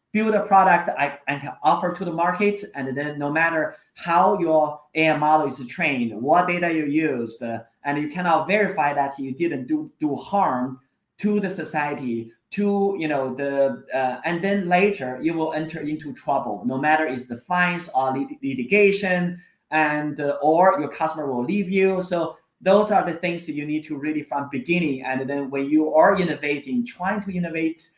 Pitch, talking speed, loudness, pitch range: 155 Hz, 185 wpm, -22 LUFS, 140-180 Hz